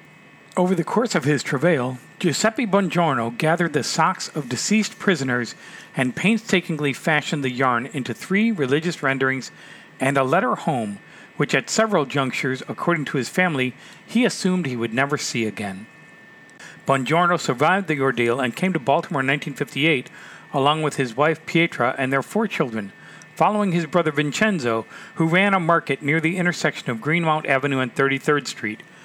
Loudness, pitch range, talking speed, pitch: -21 LUFS, 135-175 Hz, 160 wpm, 150 Hz